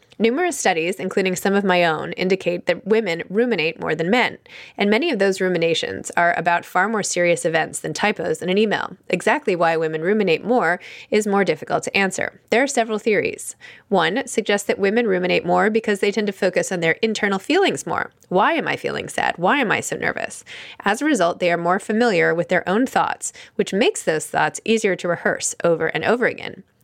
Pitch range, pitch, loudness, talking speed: 175-225 Hz, 195 Hz, -20 LUFS, 205 wpm